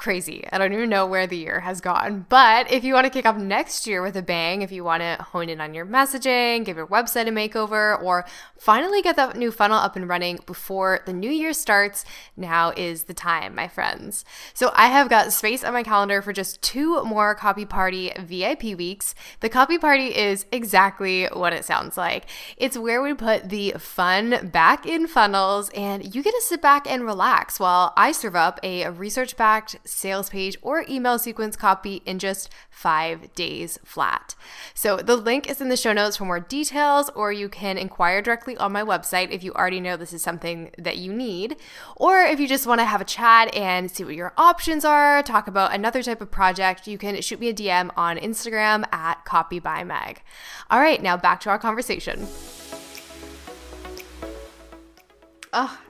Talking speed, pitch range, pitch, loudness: 200 wpm, 185-235 Hz, 200 Hz, -21 LUFS